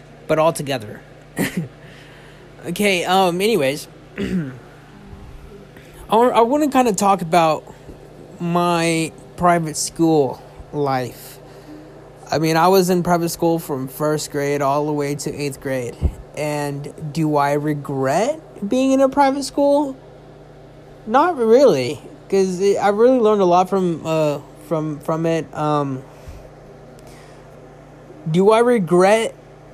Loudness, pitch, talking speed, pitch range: -18 LUFS, 165 Hz, 120 wpm, 145-195 Hz